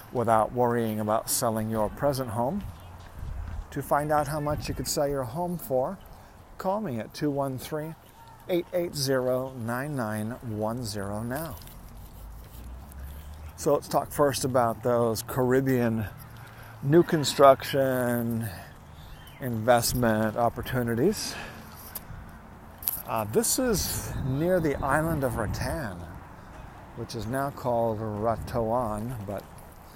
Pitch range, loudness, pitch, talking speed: 105-135 Hz, -27 LUFS, 120 Hz, 95 wpm